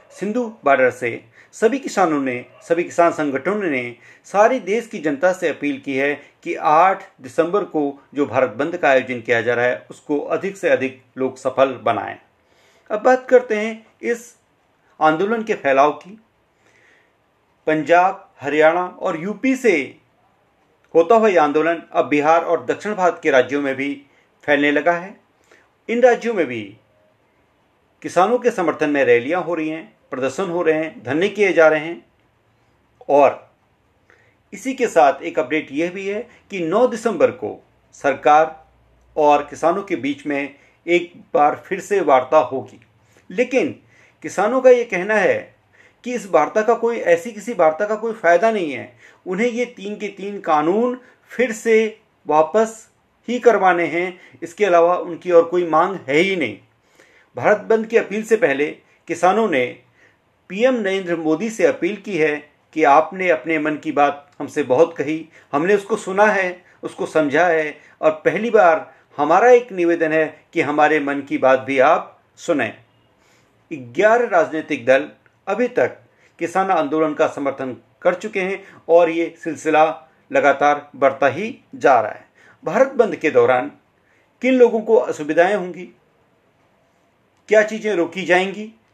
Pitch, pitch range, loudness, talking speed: 170 Hz, 150-215 Hz, -18 LUFS, 160 wpm